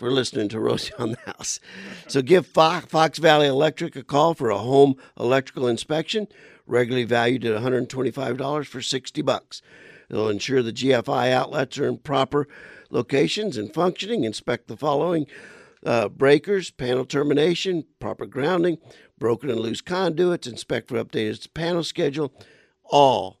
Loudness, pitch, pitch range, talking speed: -23 LUFS, 140 Hz, 125-160 Hz, 150 wpm